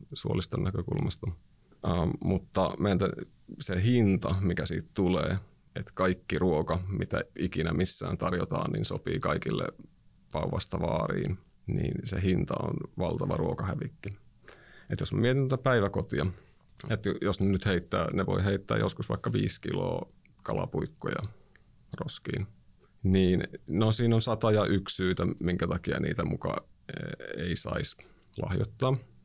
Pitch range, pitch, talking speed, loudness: 90-110 Hz, 95 Hz, 130 wpm, -30 LUFS